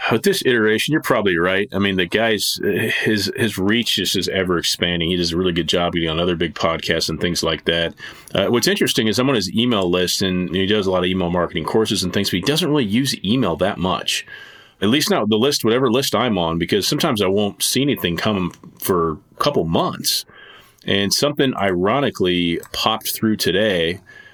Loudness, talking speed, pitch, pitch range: -18 LUFS, 210 wpm, 95 Hz, 85-110 Hz